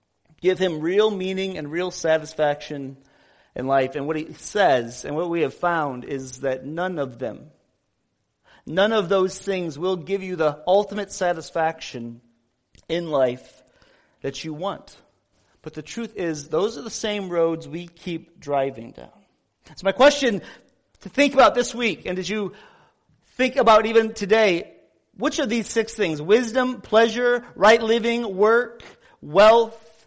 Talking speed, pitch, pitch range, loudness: 155 wpm, 185 Hz, 155-220 Hz, -22 LUFS